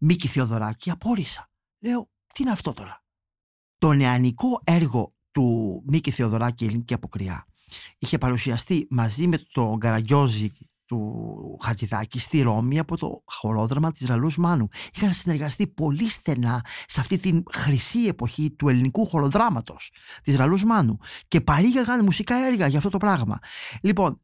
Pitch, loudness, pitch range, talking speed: 140 Hz, -24 LUFS, 115-175 Hz, 140 wpm